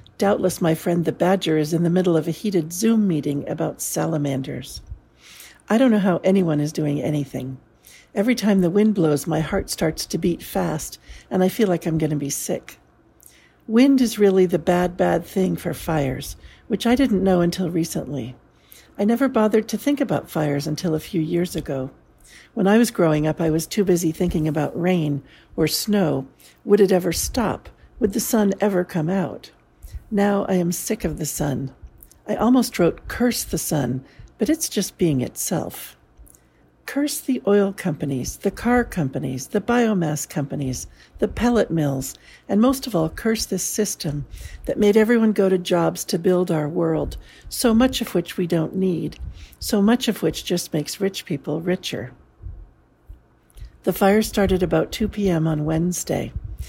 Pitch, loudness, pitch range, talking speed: 175 Hz, -21 LUFS, 155-205 Hz, 175 wpm